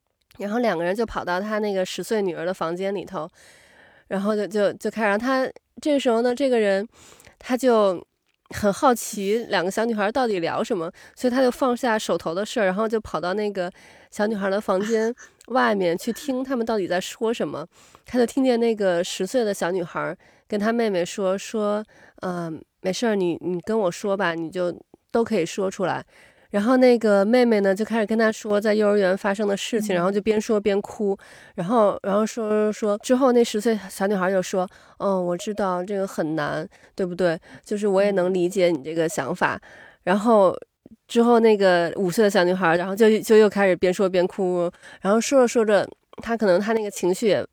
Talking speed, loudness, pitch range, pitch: 290 characters per minute, -22 LUFS, 185-225 Hz, 205 Hz